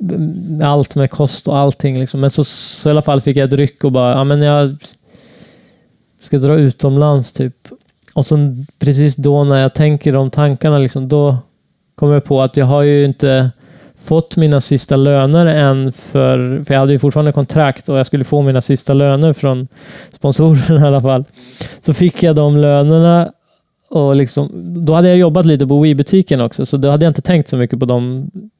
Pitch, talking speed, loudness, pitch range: 145 Hz, 195 wpm, -12 LUFS, 135-155 Hz